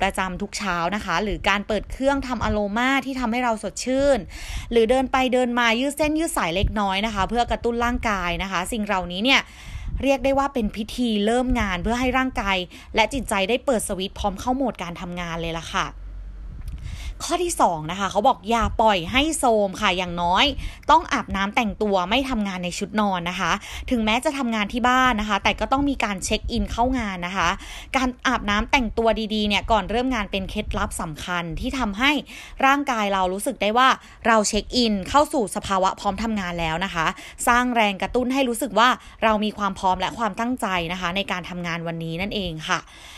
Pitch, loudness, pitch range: 215 Hz, -22 LUFS, 190-250 Hz